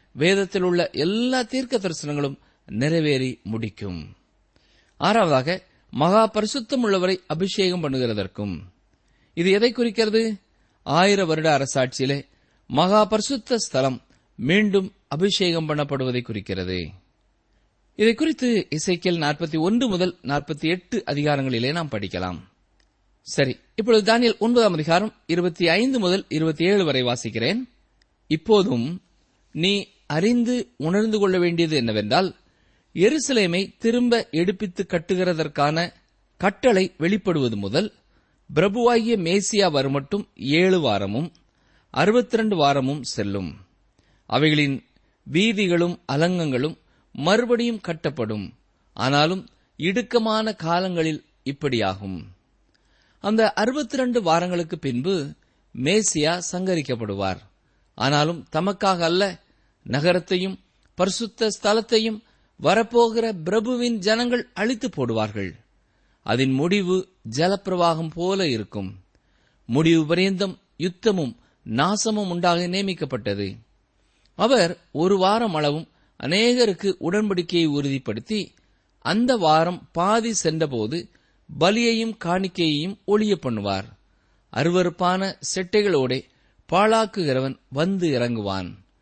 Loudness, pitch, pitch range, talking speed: -22 LUFS, 175 Hz, 135-205 Hz, 80 wpm